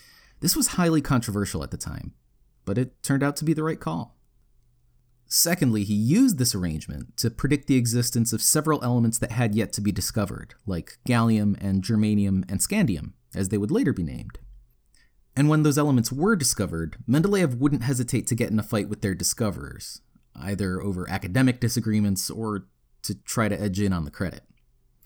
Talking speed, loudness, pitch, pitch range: 180 wpm, -24 LUFS, 115 Hz, 100-130 Hz